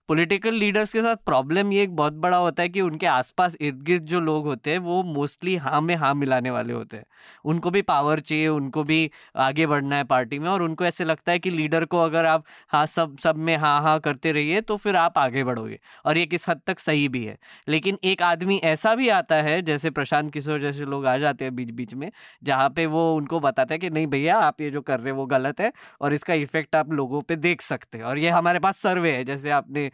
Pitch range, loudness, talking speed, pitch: 145-175 Hz, -23 LUFS, 250 wpm, 155 Hz